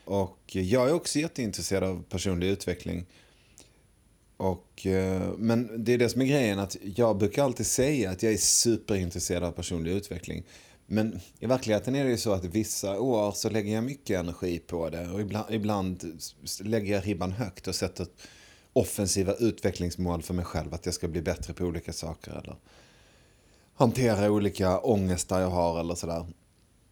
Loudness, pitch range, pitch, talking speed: -29 LUFS, 90-110 Hz, 95 Hz, 170 wpm